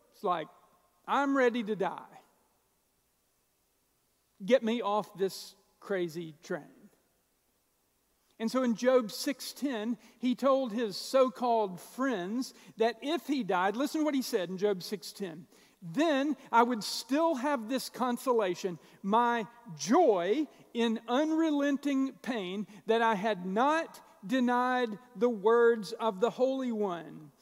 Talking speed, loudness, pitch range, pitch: 125 wpm, -31 LUFS, 205-260 Hz, 235 Hz